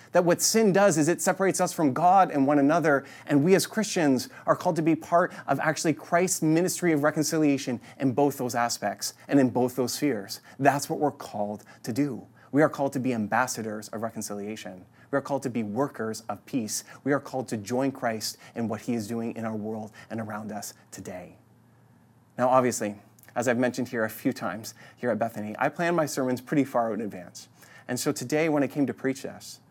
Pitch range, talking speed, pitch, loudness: 115-150 Hz, 215 wpm, 130 Hz, -26 LUFS